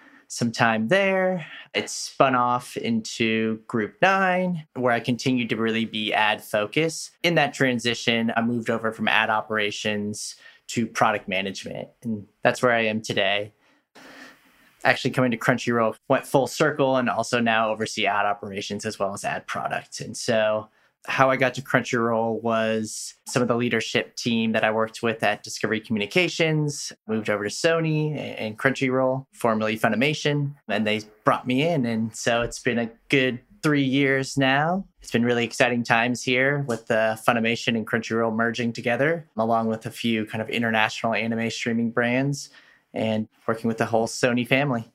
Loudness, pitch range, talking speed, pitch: -24 LUFS, 110-135 Hz, 165 wpm, 115 Hz